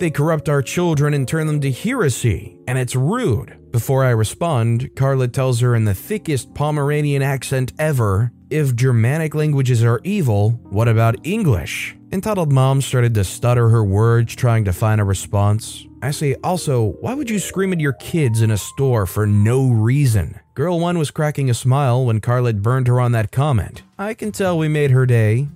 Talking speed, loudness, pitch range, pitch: 190 wpm, -18 LUFS, 115-150 Hz, 130 Hz